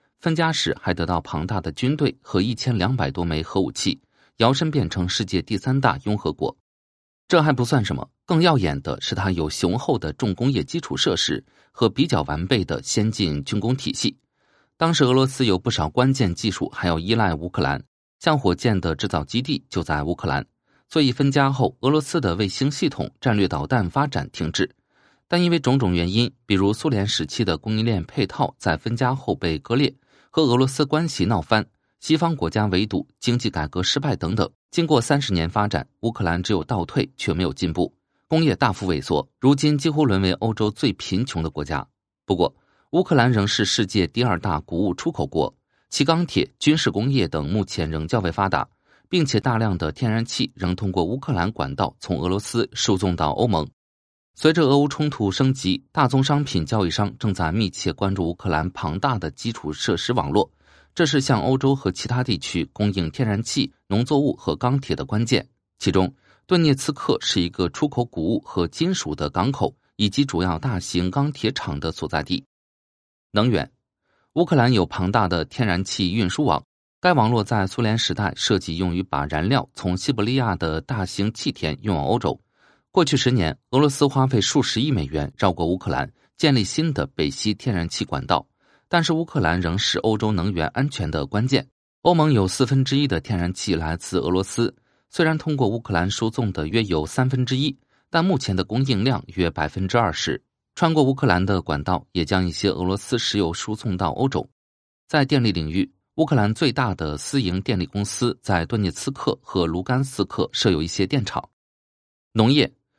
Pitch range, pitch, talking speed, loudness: 90-135 Hz, 110 Hz, 290 characters per minute, -22 LUFS